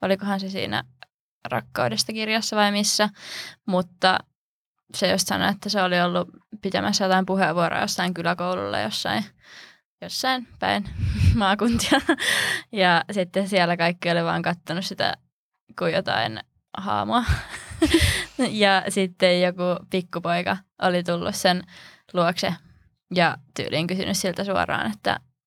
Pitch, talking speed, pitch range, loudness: 185 Hz, 115 wpm, 175-200 Hz, -23 LUFS